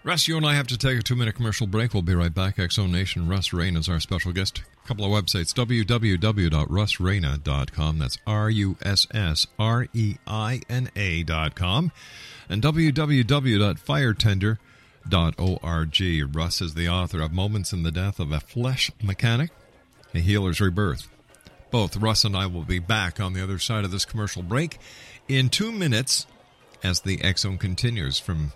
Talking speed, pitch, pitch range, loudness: 150 wpm, 100 Hz, 90-120 Hz, -24 LUFS